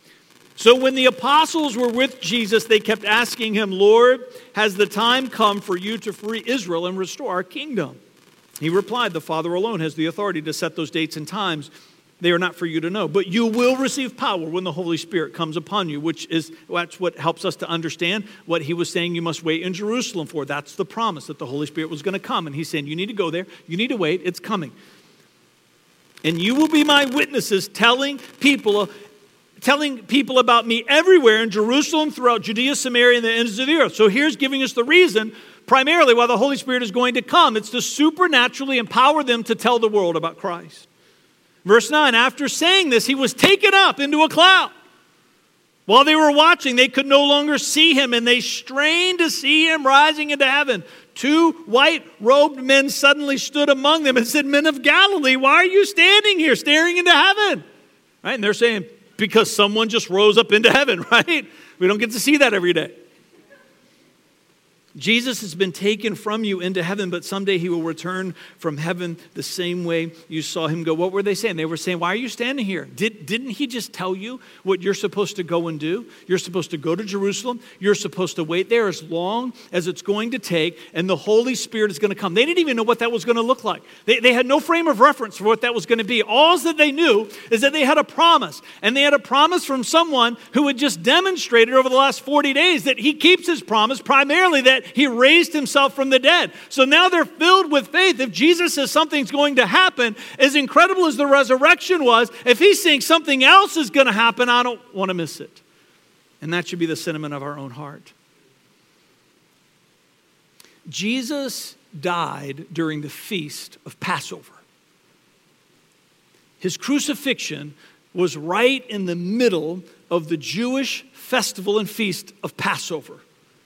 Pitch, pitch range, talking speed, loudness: 230 Hz, 185-275 Hz, 205 wpm, -17 LUFS